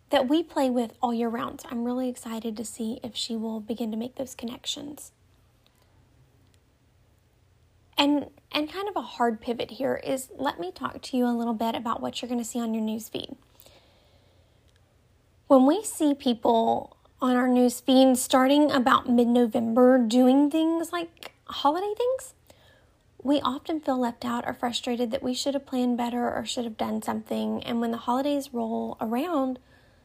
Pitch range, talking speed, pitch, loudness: 230-275 Hz, 170 wpm, 245 Hz, -26 LUFS